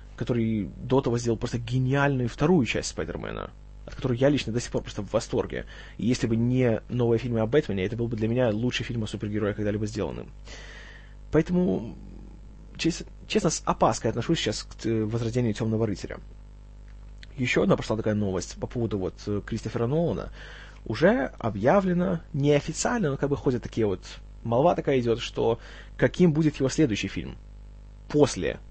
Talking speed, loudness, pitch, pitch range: 160 wpm, -26 LUFS, 120 Hz, 110-145 Hz